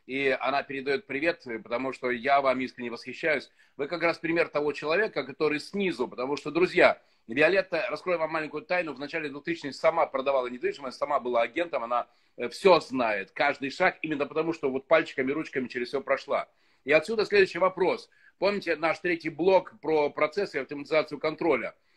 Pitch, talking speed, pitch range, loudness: 150 Hz, 170 wpm, 135-170 Hz, -28 LUFS